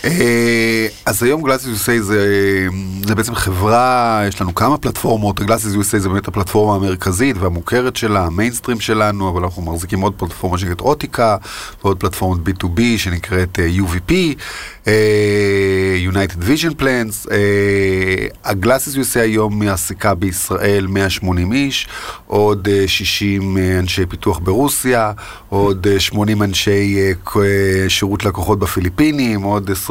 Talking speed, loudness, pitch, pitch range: 120 wpm, -15 LUFS, 100 Hz, 95-110 Hz